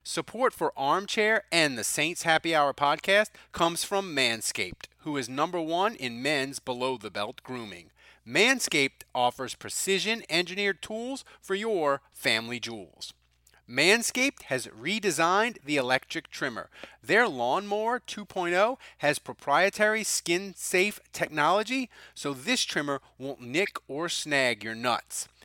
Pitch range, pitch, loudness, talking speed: 130-200 Hz, 160 Hz, -27 LUFS, 120 wpm